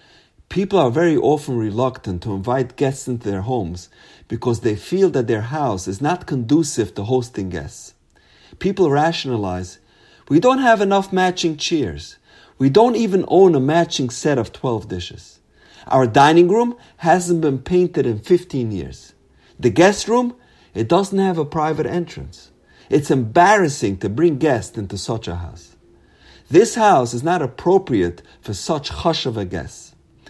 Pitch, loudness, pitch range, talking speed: 135 Hz, -18 LUFS, 105-175 Hz, 155 wpm